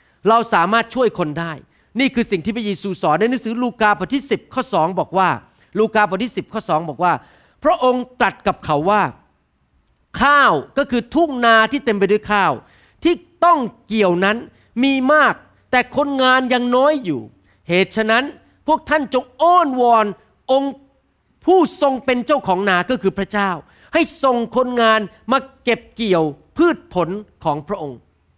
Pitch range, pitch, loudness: 190-265 Hz, 230 Hz, -17 LUFS